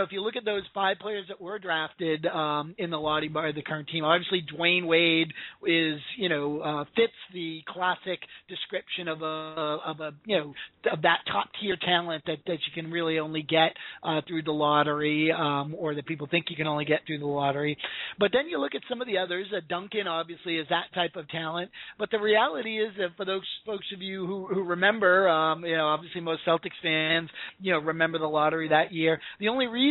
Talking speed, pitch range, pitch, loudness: 225 wpm, 155-185 Hz, 165 Hz, -28 LUFS